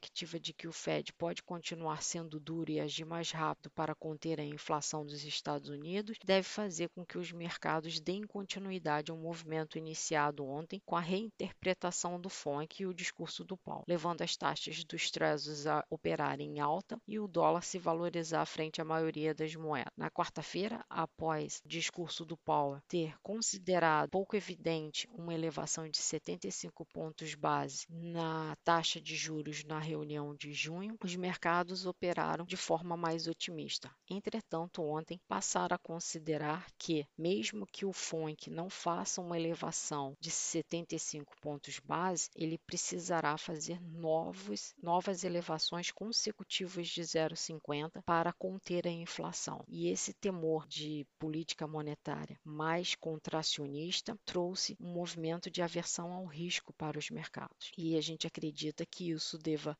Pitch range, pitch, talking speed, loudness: 155-175 Hz, 165 Hz, 150 wpm, -38 LUFS